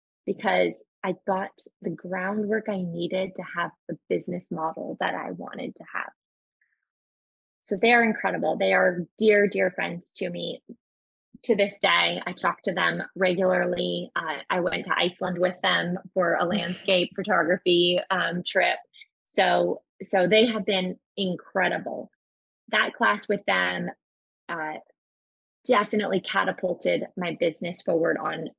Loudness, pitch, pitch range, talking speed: -25 LUFS, 185 Hz, 180-205 Hz, 140 wpm